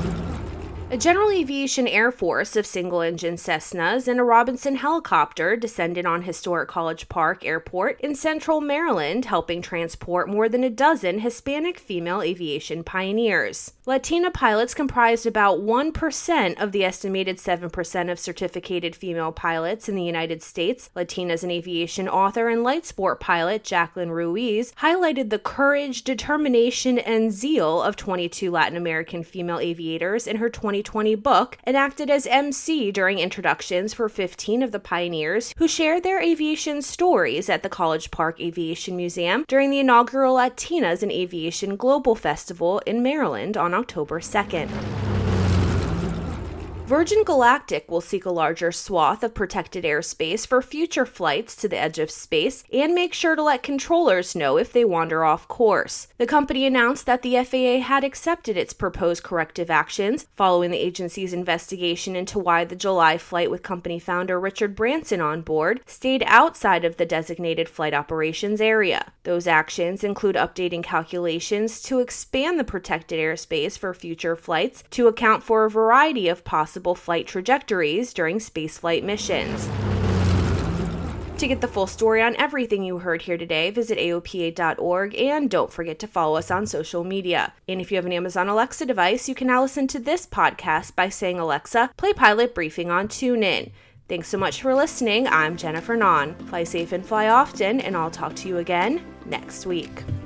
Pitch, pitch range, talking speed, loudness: 195 Hz, 170-250 Hz, 160 wpm, -22 LUFS